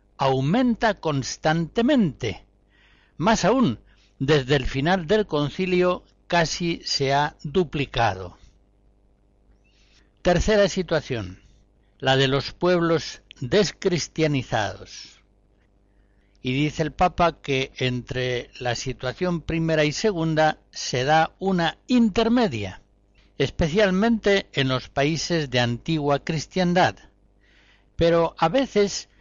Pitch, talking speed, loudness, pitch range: 145 Hz, 90 wpm, -23 LUFS, 105-175 Hz